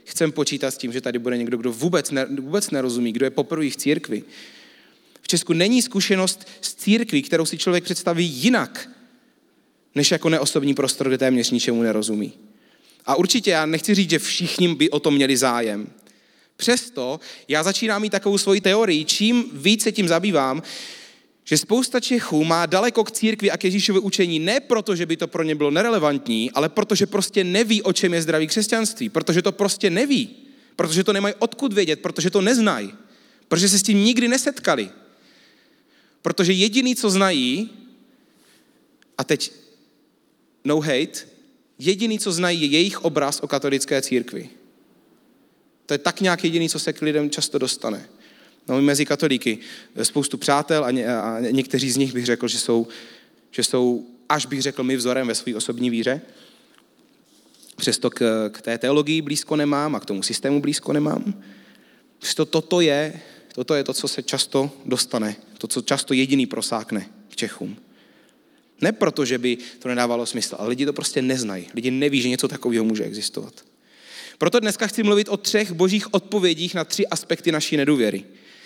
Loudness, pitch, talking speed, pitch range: -21 LUFS, 160 Hz, 170 wpm, 135-200 Hz